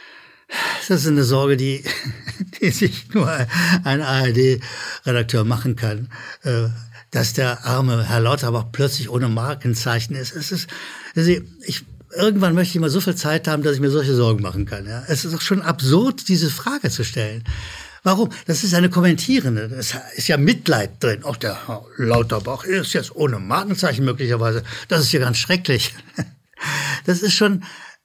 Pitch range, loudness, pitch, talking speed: 120-175 Hz, -20 LUFS, 135 Hz, 165 wpm